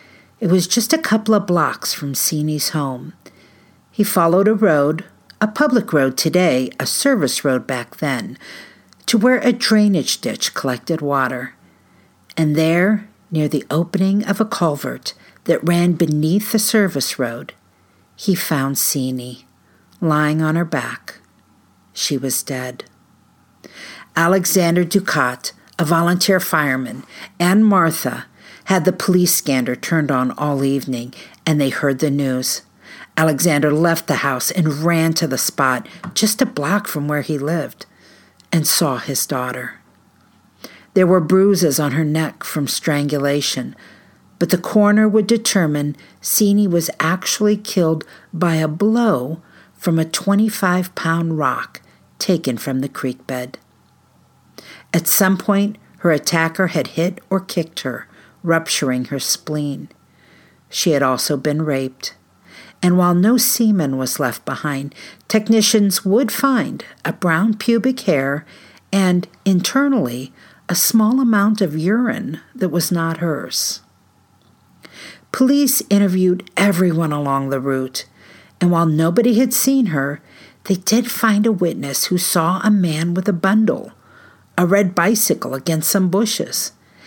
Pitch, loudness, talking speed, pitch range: 170 Hz, -17 LUFS, 135 wpm, 145-200 Hz